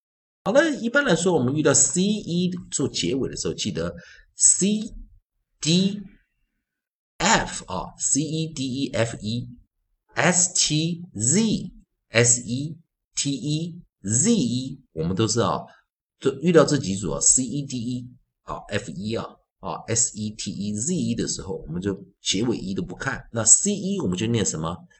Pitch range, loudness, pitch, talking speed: 115-180 Hz, -22 LUFS, 140 Hz, 215 characters per minute